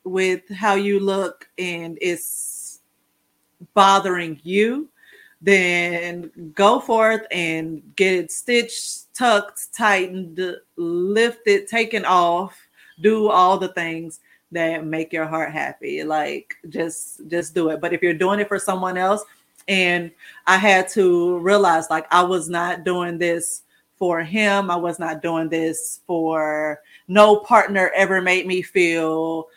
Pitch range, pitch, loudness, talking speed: 170-200 Hz, 180 Hz, -19 LUFS, 135 wpm